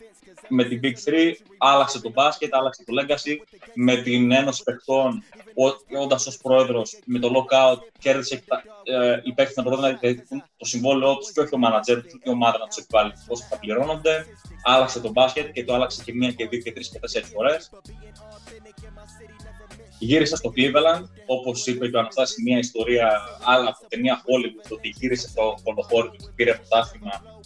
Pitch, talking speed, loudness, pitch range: 125 Hz, 180 wpm, -22 LUFS, 115-135 Hz